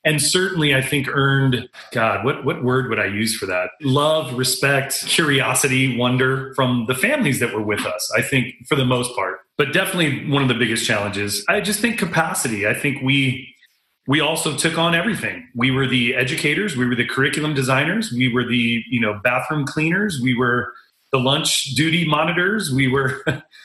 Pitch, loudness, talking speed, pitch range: 135 Hz, -19 LUFS, 190 wpm, 125-155 Hz